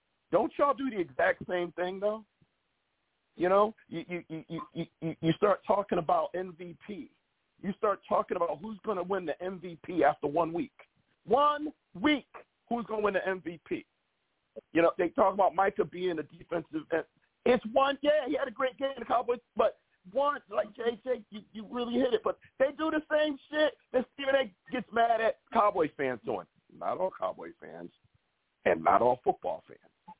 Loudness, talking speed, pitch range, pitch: -31 LUFS, 180 wpm, 180-270 Hz, 215 Hz